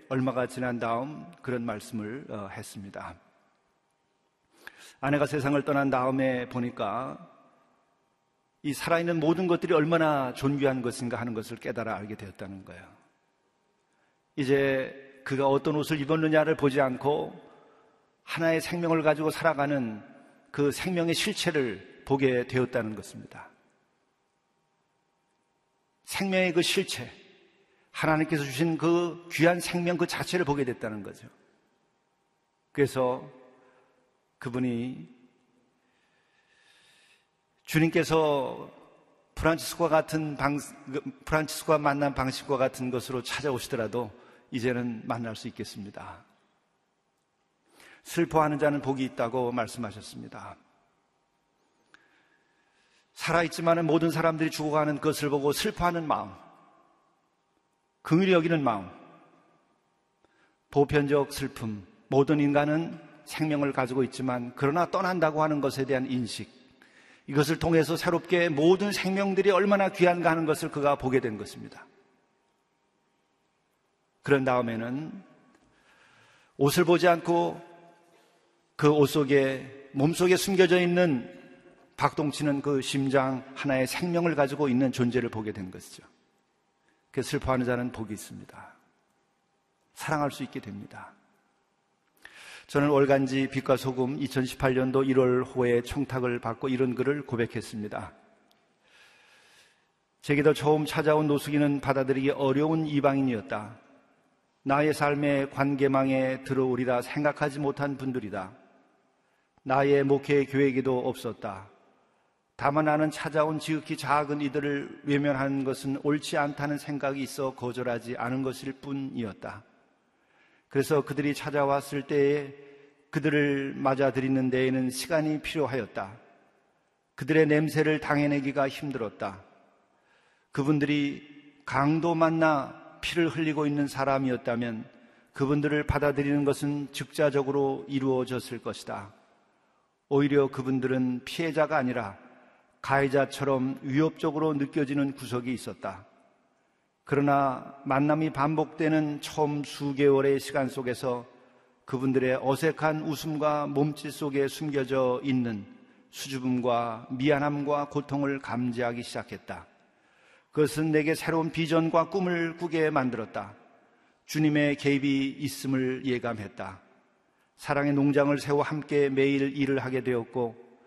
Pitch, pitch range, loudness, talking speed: 140 Hz, 130-155 Hz, -27 LUFS, 265 characters per minute